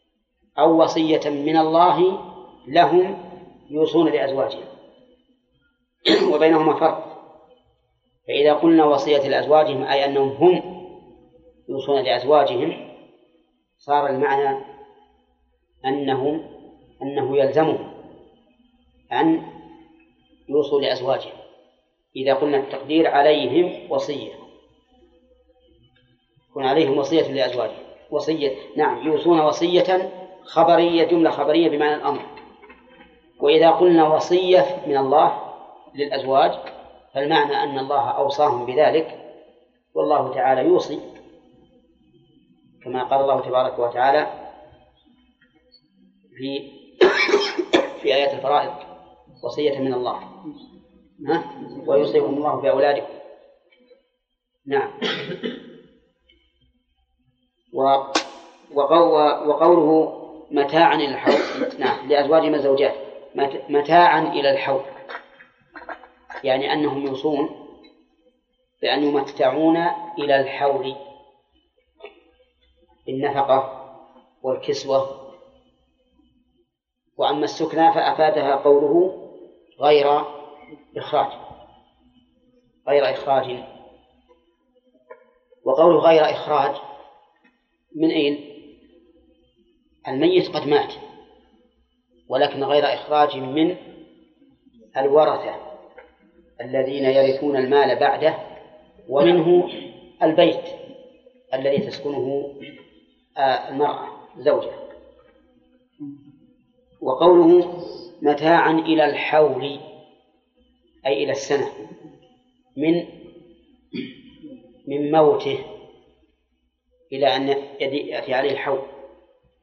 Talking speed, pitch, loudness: 70 wpm, 160 Hz, -19 LUFS